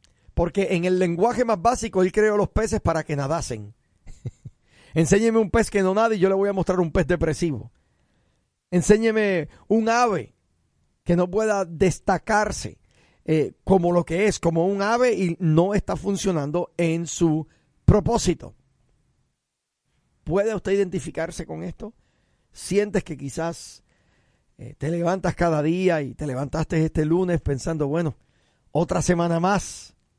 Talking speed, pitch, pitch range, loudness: 145 wpm, 175 Hz, 155-200 Hz, -23 LUFS